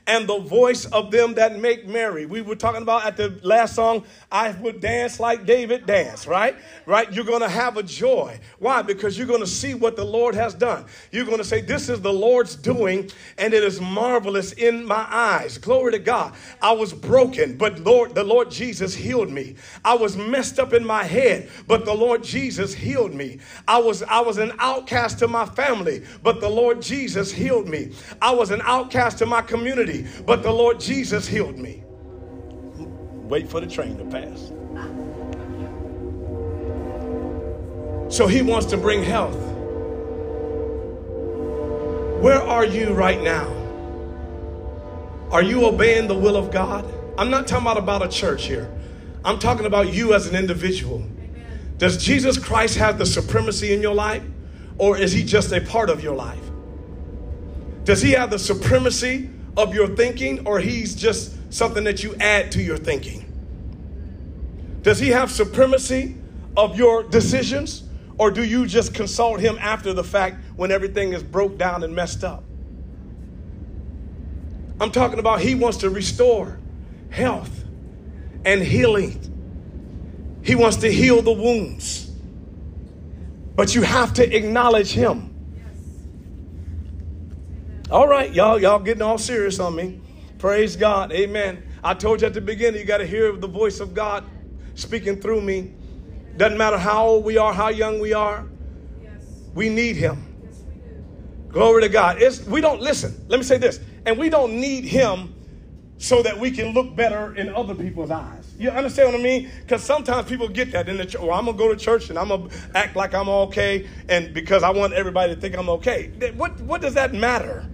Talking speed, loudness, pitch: 175 wpm, -20 LUFS, 210 Hz